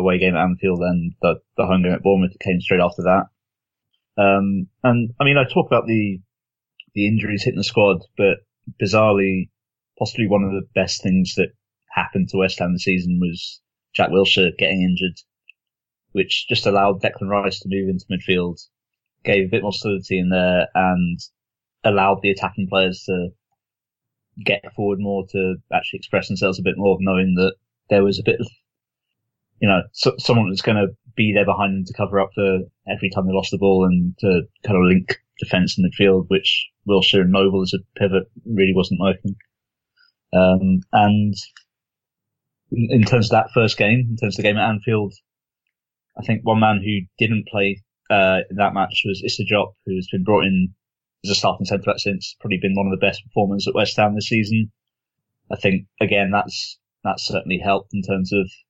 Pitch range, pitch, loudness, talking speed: 95-110 Hz, 100 Hz, -19 LUFS, 190 wpm